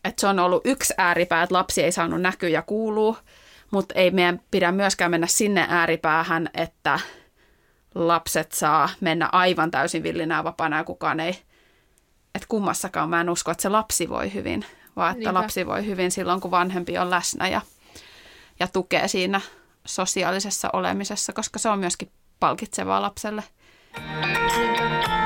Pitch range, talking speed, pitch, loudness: 170-200 Hz, 150 wpm, 180 Hz, -23 LUFS